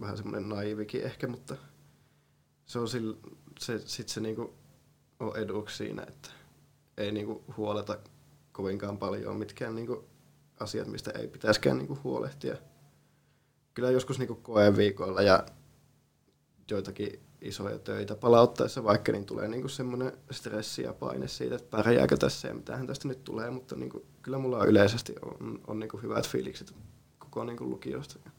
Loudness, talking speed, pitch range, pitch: -31 LUFS, 140 wpm, 105-125 Hz, 110 Hz